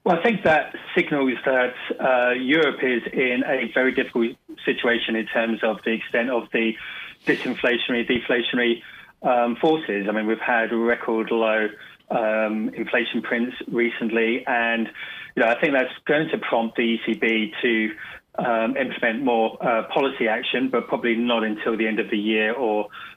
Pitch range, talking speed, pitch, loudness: 110-125 Hz, 165 wpm, 115 Hz, -22 LUFS